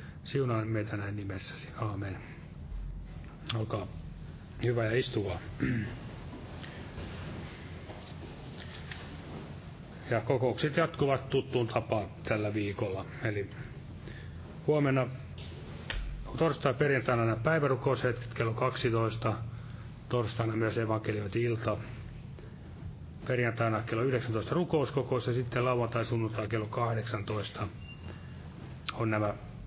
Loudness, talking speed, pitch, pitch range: -33 LUFS, 80 wpm, 115 Hz, 105-130 Hz